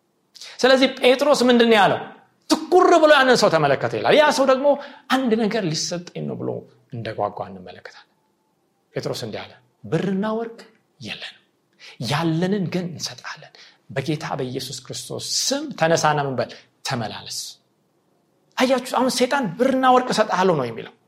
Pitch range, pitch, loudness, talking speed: 165-260 Hz, 215 Hz, -20 LUFS, 125 wpm